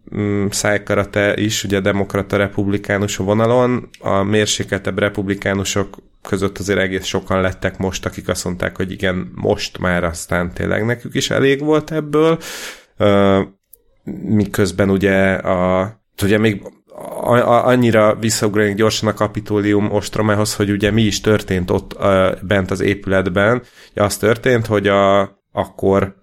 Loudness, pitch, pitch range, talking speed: -17 LUFS, 100 Hz, 95-105 Hz, 125 wpm